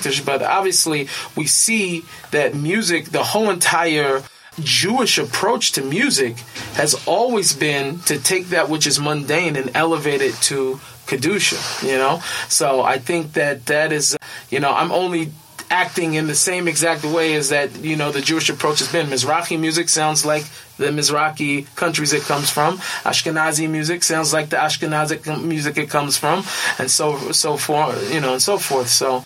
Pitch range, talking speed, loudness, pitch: 145-165 Hz, 170 wpm, -18 LUFS, 155 Hz